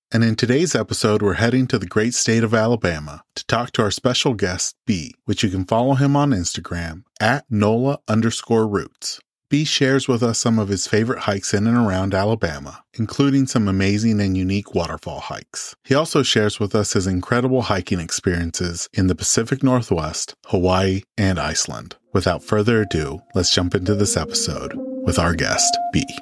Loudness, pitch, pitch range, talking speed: -20 LUFS, 110 Hz, 95-125 Hz, 180 wpm